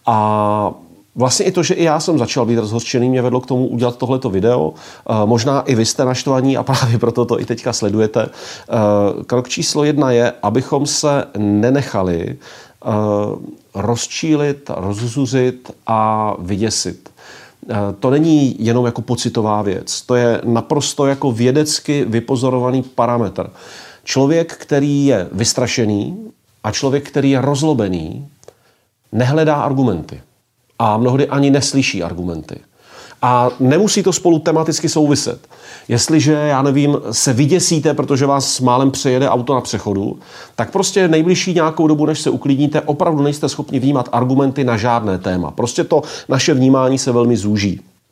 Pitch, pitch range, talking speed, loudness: 130 Hz, 115-145 Hz, 140 wpm, -15 LUFS